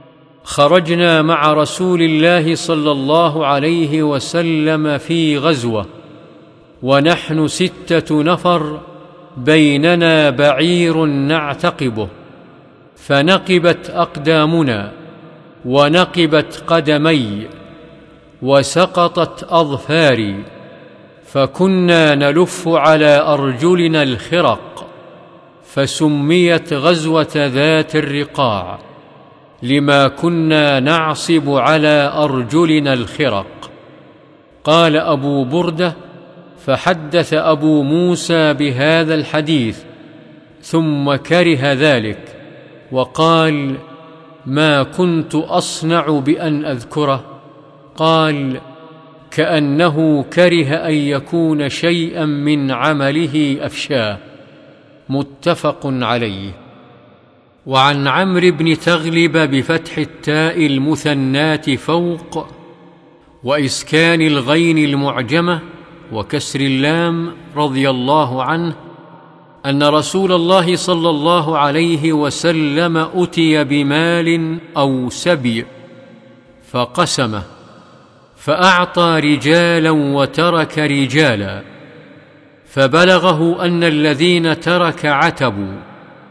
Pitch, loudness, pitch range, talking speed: 155 Hz, -14 LUFS, 145-165 Hz, 70 wpm